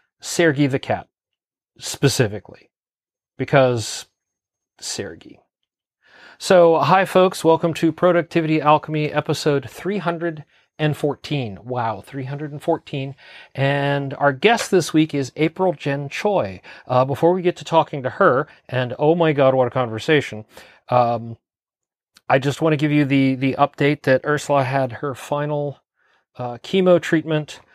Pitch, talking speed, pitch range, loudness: 145 Hz, 130 wpm, 130-160 Hz, -19 LUFS